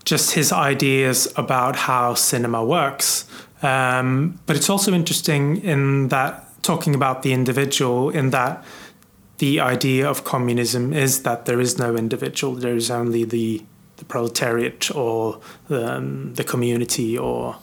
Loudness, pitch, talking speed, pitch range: -20 LUFS, 130 Hz, 145 wpm, 120-140 Hz